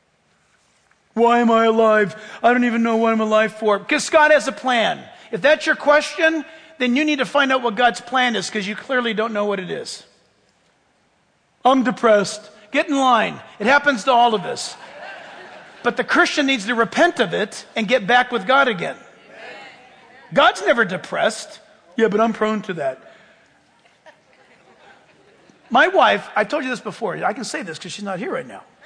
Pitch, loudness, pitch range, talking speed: 240 Hz, -18 LUFS, 215-270 Hz, 185 wpm